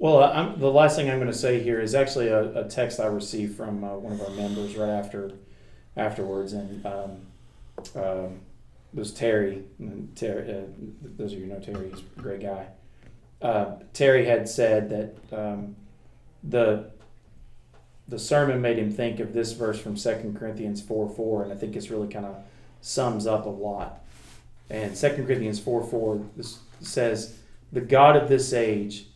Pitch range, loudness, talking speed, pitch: 100-120 Hz, -26 LUFS, 180 wpm, 110 Hz